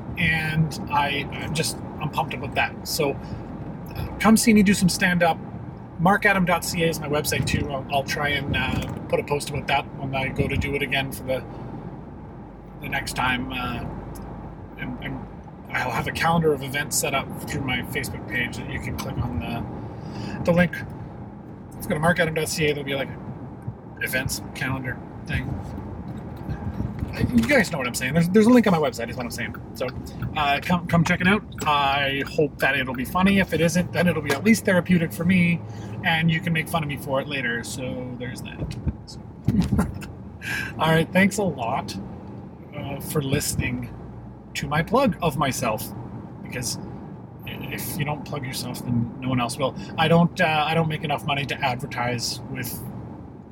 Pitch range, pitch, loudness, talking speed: 130-170 Hz, 150 Hz, -24 LUFS, 185 wpm